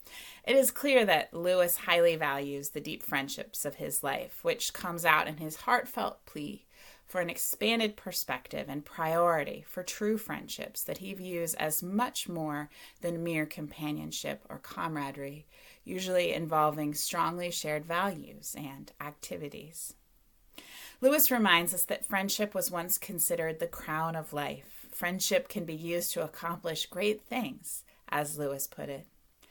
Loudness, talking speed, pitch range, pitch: -31 LUFS, 145 wpm, 155-195 Hz, 170 Hz